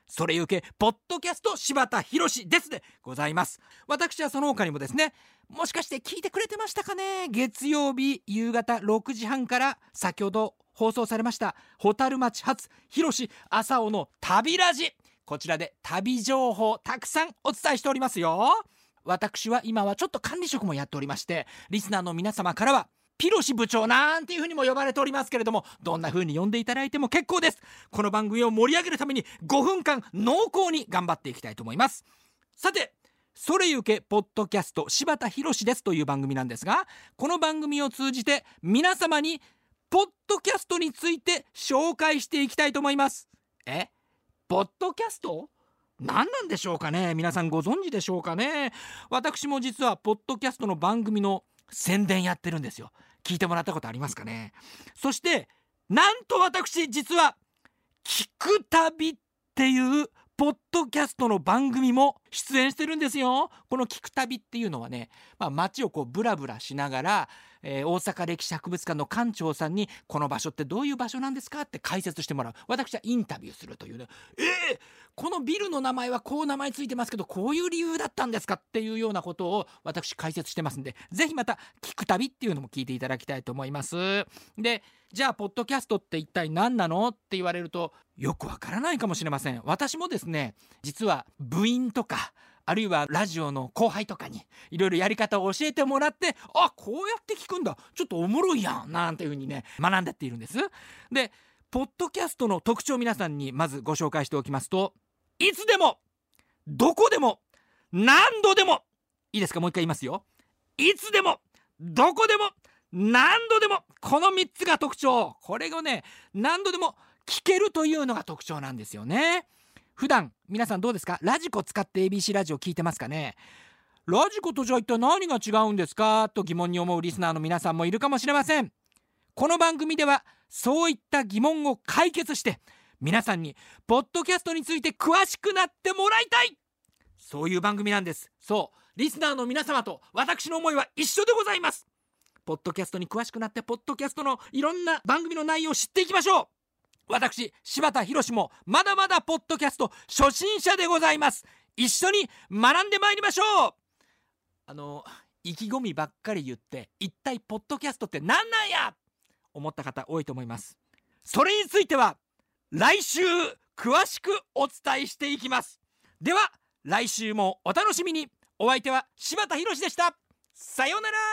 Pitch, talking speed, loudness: 245 Hz, 360 characters per minute, -26 LUFS